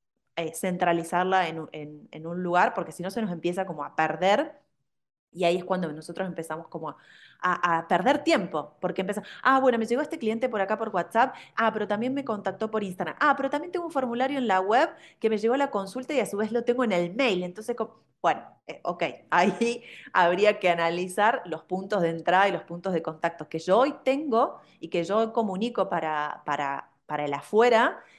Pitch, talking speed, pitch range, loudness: 190 Hz, 220 wpm, 170-235 Hz, -26 LUFS